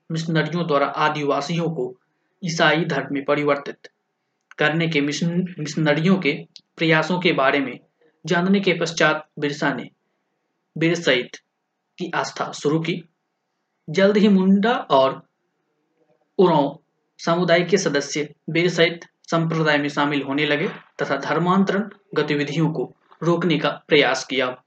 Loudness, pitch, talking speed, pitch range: -21 LUFS, 160 Hz, 110 wpm, 150-180 Hz